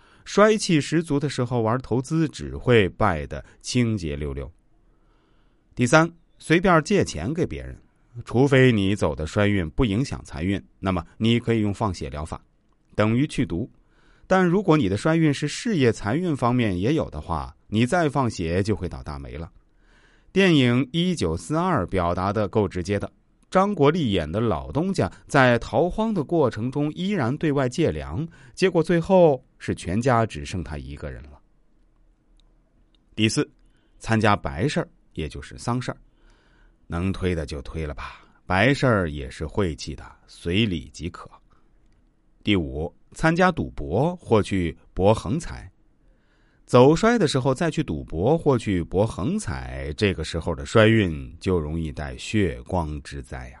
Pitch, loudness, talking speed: 110 Hz, -23 LUFS, 225 characters per minute